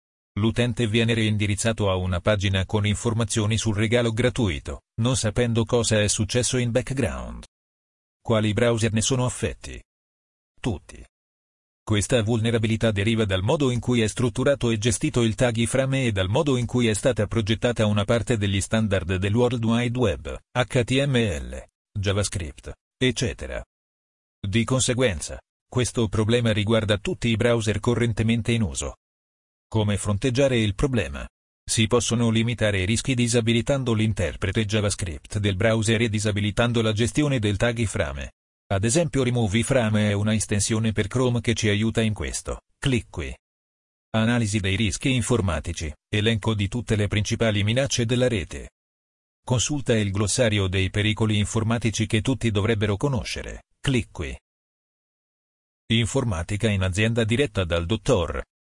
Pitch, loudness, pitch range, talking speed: 110 Hz, -23 LUFS, 100-120 Hz, 140 wpm